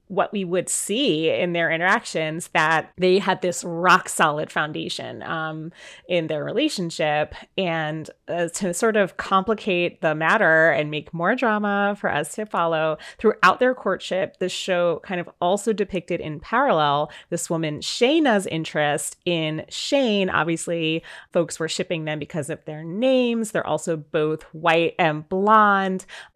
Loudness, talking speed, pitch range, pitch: -22 LUFS, 150 wpm, 160-195 Hz, 175 Hz